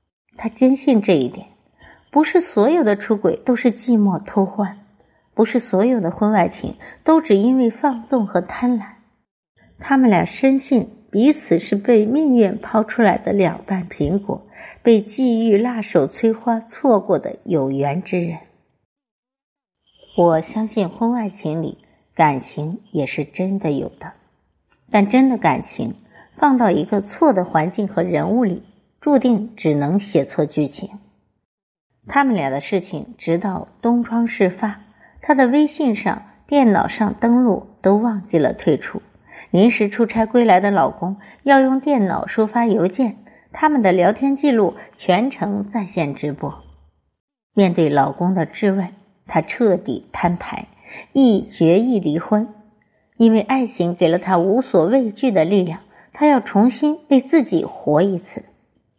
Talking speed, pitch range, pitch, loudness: 210 characters per minute, 180-245 Hz, 210 Hz, -18 LUFS